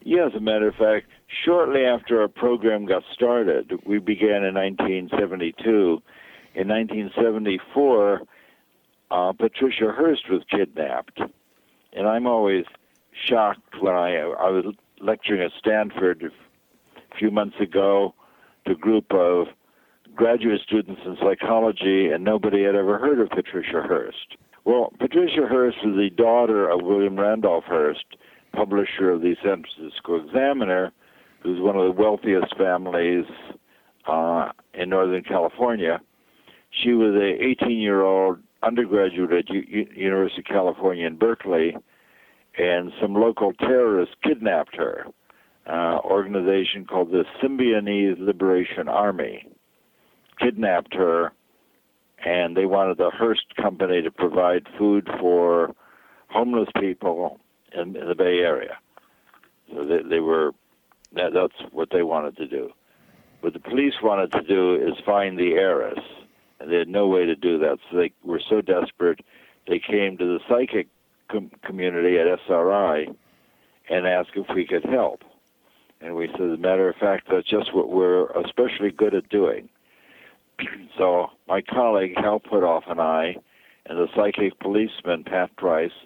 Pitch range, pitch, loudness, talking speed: 90-115 Hz, 100 Hz, -22 LUFS, 145 wpm